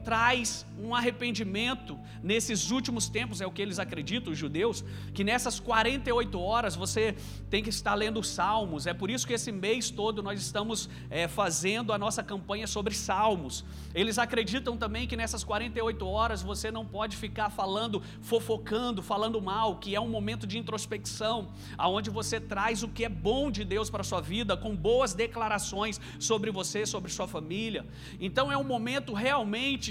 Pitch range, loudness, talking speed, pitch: 195-230 Hz, -31 LUFS, 170 wpm, 215 Hz